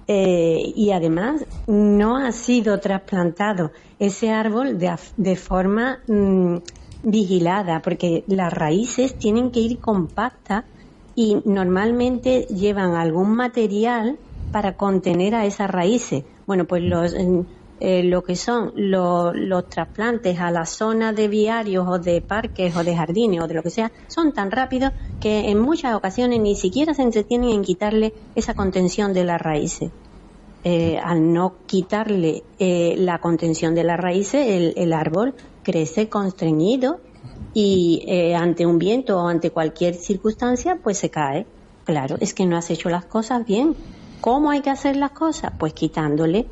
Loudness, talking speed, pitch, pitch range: -20 LUFS, 155 wpm, 195 Hz, 175-225 Hz